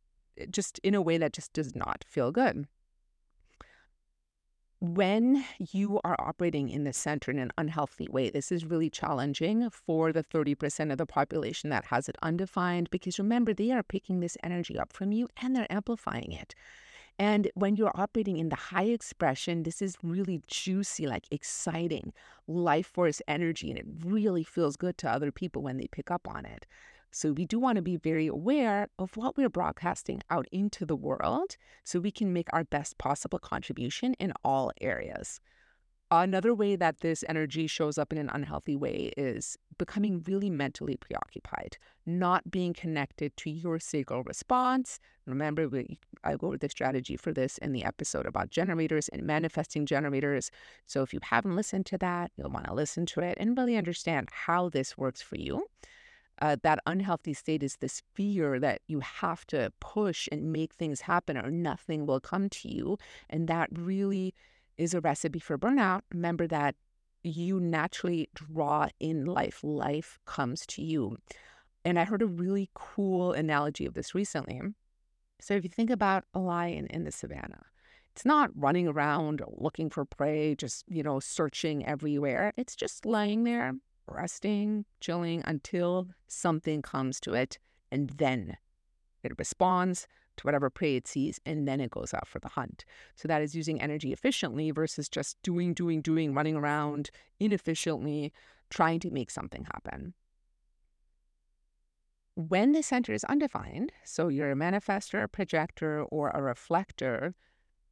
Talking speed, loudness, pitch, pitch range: 170 wpm, -32 LUFS, 165 Hz, 145-190 Hz